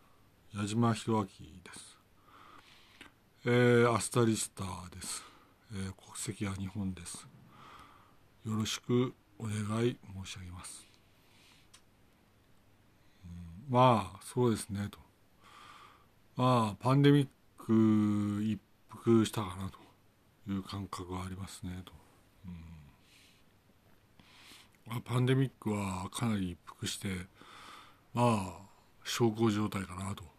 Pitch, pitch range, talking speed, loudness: 105 Hz, 95-115 Hz, 200 characters per minute, -33 LUFS